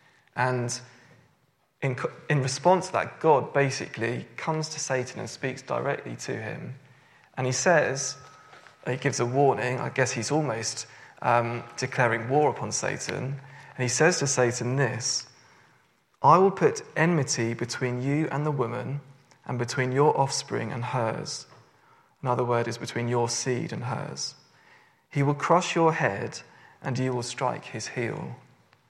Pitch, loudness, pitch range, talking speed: 130 Hz, -27 LUFS, 125-145 Hz, 150 wpm